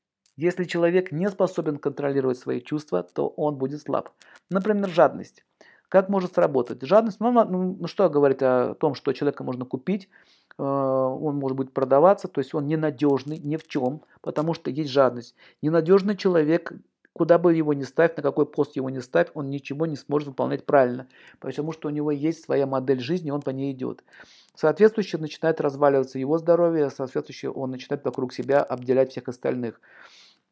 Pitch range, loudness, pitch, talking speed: 135-170 Hz, -24 LUFS, 150 Hz, 165 wpm